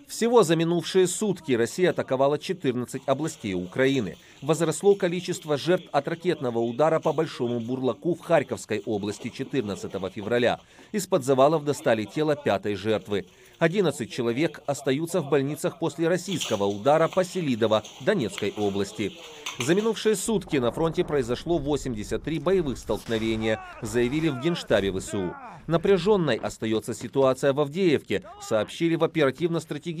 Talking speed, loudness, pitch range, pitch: 125 wpm, -26 LUFS, 120-170 Hz, 145 Hz